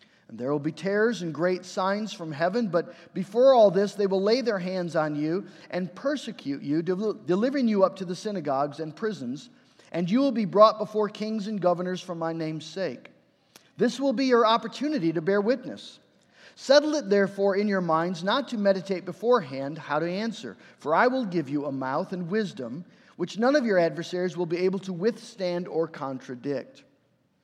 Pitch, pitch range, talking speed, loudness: 190 Hz, 170-225 Hz, 190 wpm, -26 LUFS